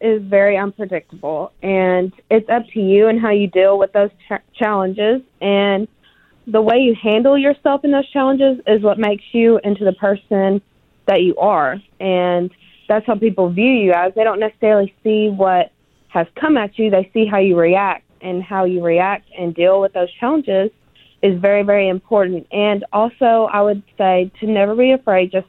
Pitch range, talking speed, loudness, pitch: 190-220 Hz, 185 wpm, -16 LUFS, 205 Hz